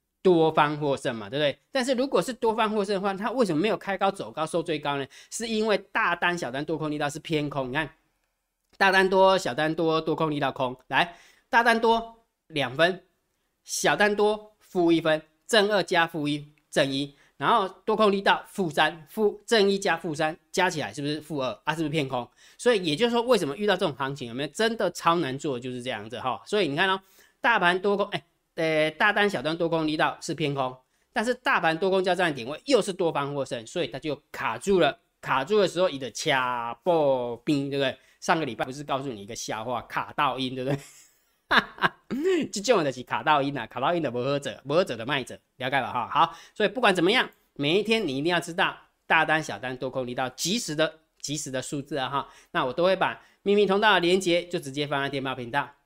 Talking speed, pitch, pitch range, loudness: 320 characters per minute, 160 Hz, 140-195 Hz, -26 LUFS